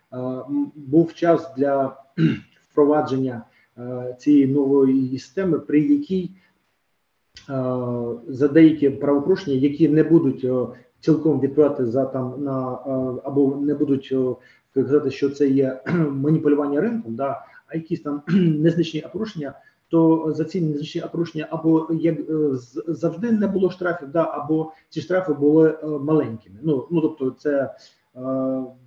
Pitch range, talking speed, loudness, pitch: 130-160 Hz, 120 wpm, -21 LUFS, 145 Hz